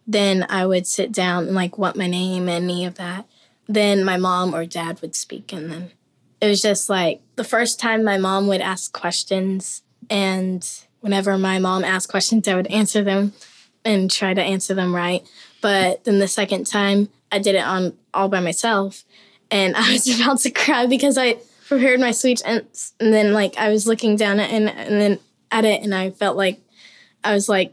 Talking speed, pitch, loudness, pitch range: 205 wpm, 195 Hz, -19 LUFS, 185-215 Hz